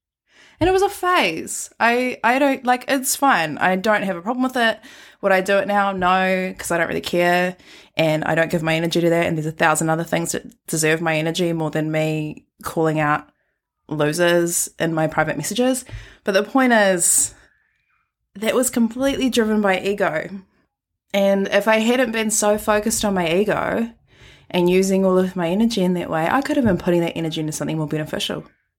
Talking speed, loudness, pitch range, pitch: 200 wpm, -19 LUFS, 165-225 Hz, 190 Hz